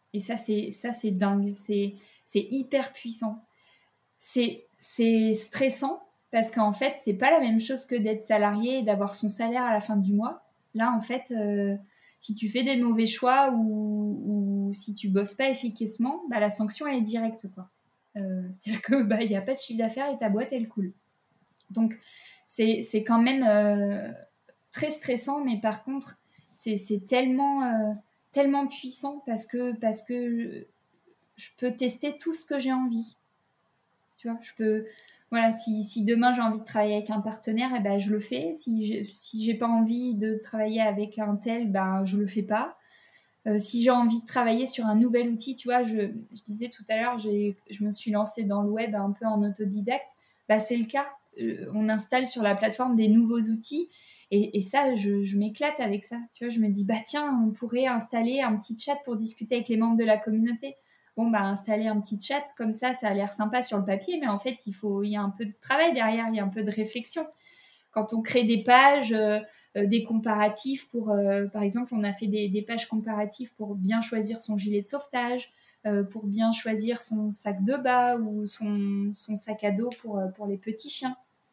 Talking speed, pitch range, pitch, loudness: 215 wpm, 210-245 Hz, 225 Hz, -27 LUFS